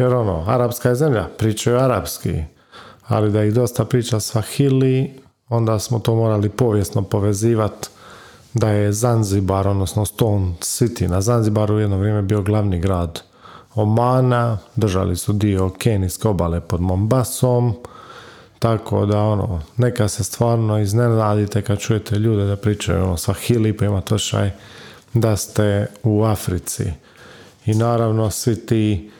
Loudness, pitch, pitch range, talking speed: -19 LUFS, 105 Hz, 100-115 Hz, 135 wpm